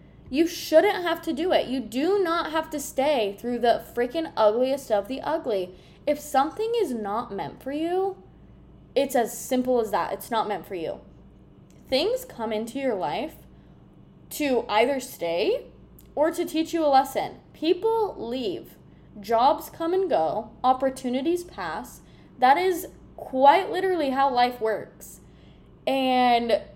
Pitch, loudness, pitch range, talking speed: 275 Hz, -25 LUFS, 245-330 Hz, 150 wpm